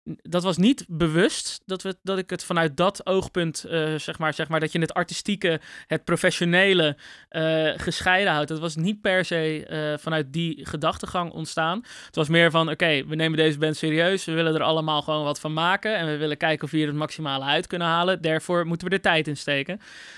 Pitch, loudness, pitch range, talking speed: 165 Hz, -24 LUFS, 155-180 Hz, 220 wpm